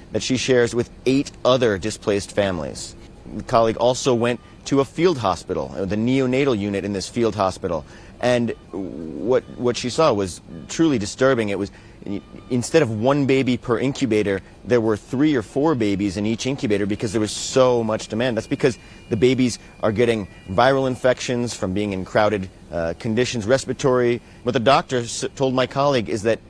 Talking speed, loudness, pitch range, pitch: 175 wpm, -21 LUFS, 100-130 Hz, 115 Hz